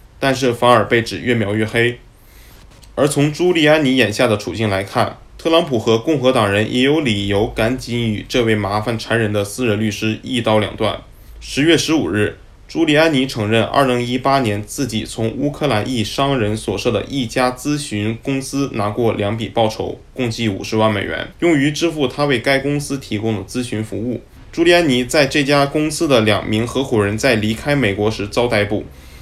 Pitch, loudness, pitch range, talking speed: 115 Hz, -17 LUFS, 105-135 Hz, 290 characters per minute